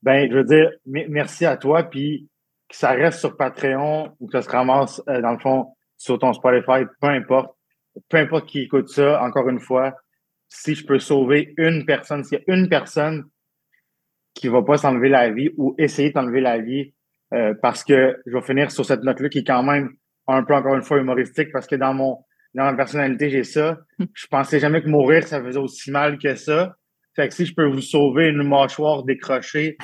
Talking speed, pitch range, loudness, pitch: 215 wpm, 130-150 Hz, -19 LUFS, 140 Hz